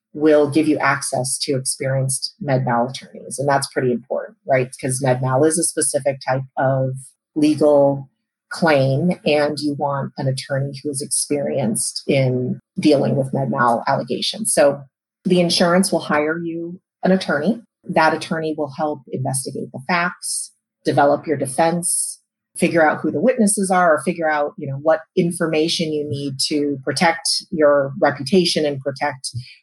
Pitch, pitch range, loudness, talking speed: 150 Hz, 135-165 Hz, -19 LUFS, 150 wpm